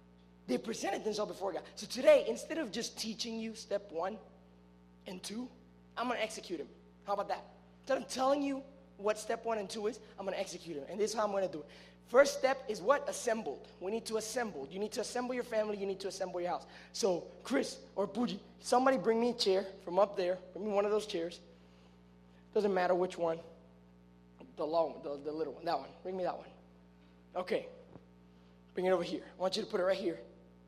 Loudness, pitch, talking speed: -35 LUFS, 190 Hz, 230 wpm